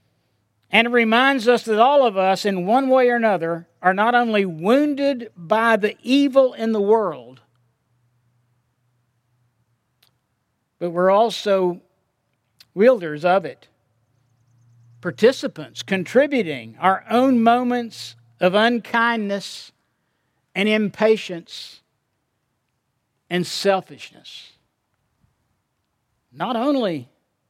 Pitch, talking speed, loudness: 180 Hz, 90 wpm, -19 LUFS